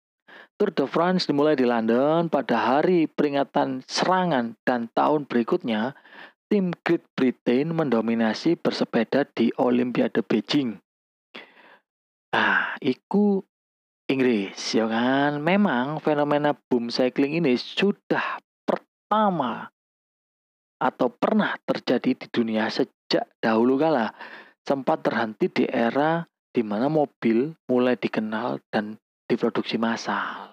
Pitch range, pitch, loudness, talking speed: 115-160 Hz, 130 Hz, -24 LUFS, 105 wpm